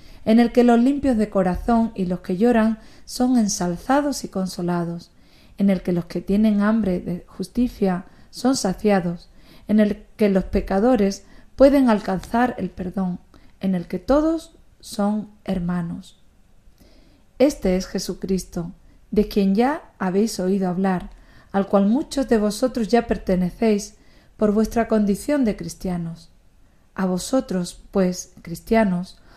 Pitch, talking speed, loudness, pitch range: 200 Hz, 135 wpm, -21 LUFS, 185-230 Hz